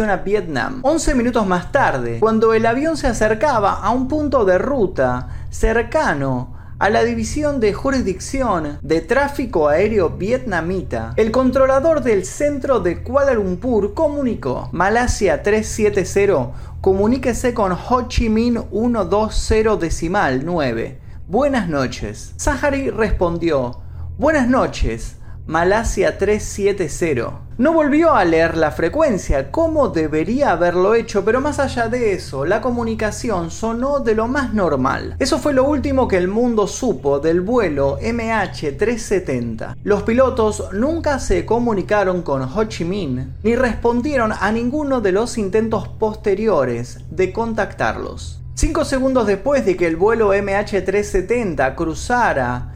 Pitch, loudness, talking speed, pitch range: 215 Hz, -18 LUFS, 130 wpm, 175-255 Hz